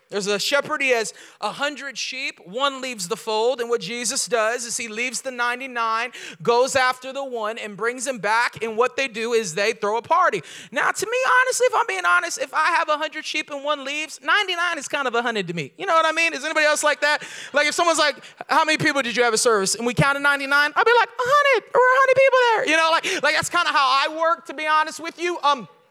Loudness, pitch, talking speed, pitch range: -20 LUFS, 285 Hz, 265 wpm, 235-325 Hz